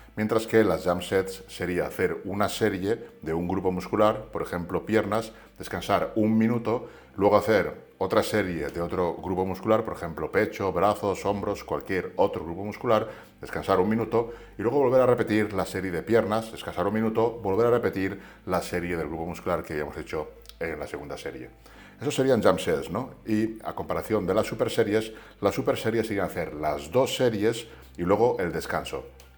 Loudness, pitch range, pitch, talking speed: -27 LUFS, 95-110 Hz, 105 Hz, 185 wpm